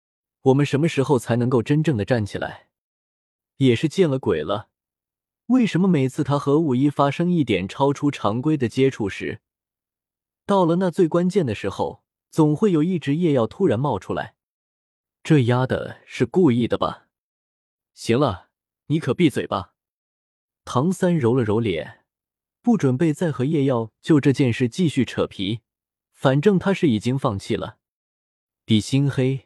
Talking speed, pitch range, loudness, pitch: 225 characters per minute, 115-160 Hz, -21 LUFS, 135 Hz